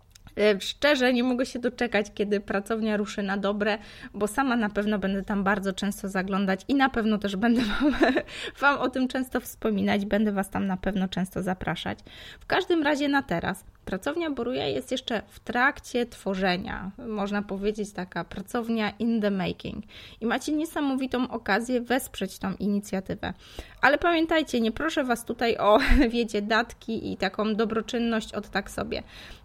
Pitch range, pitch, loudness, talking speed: 200-250 Hz, 215 Hz, -27 LUFS, 160 wpm